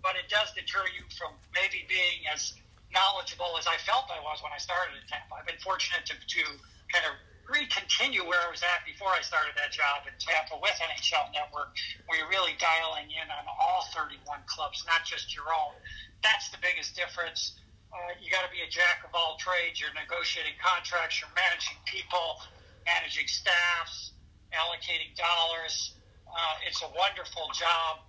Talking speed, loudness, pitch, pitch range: 180 wpm, -29 LUFS, 175 Hz, 160-190 Hz